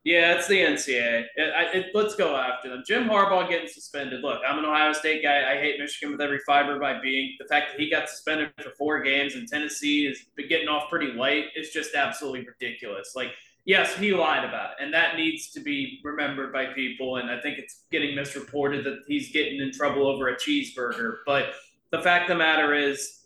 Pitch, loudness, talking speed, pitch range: 150 Hz, -25 LUFS, 215 wpm, 140-170 Hz